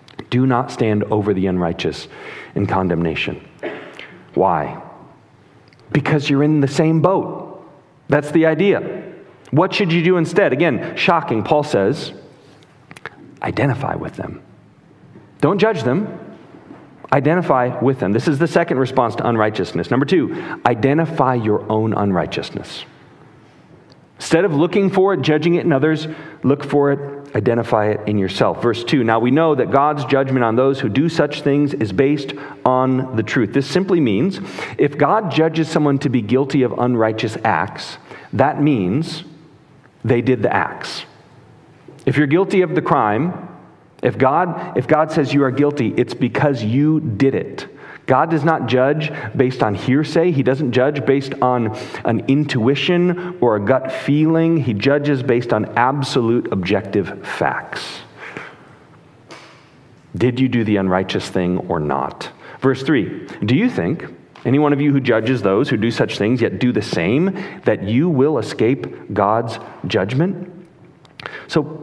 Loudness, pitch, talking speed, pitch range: -17 LUFS, 140 Hz, 150 wpm, 120-160 Hz